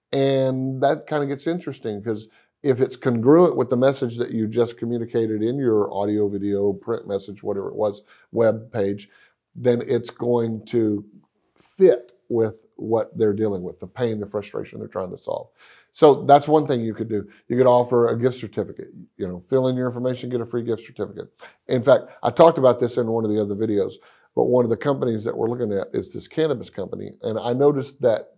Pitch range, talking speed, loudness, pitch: 110-130 Hz, 210 wpm, -22 LUFS, 120 Hz